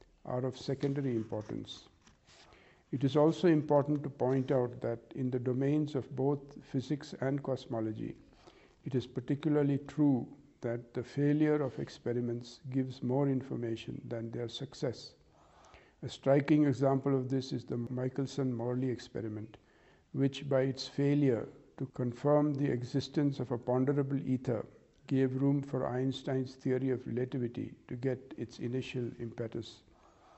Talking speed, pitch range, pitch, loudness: 135 wpm, 125-140 Hz, 130 Hz, -34 LUFS